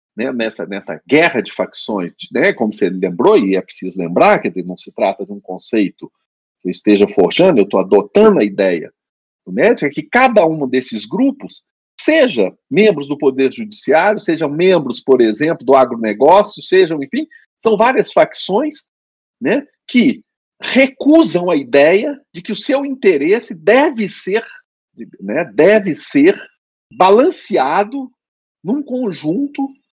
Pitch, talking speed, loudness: 210 Hz, 145 wpm, -14 LUFS